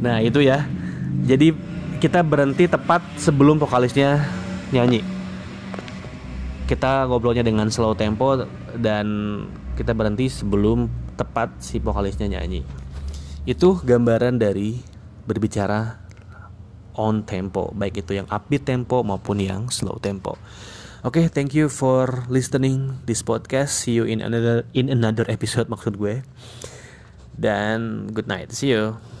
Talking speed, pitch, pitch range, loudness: 125 wpm, 115 Hz, 105-130 Hz, -21 LUFS